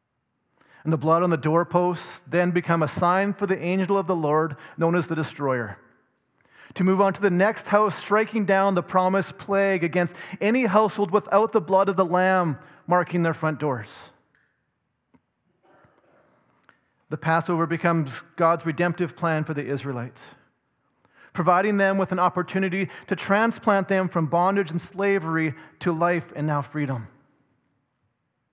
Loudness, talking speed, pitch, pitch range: -23 LUFS, 150 wpm, 175 Hz, 160-195 Hz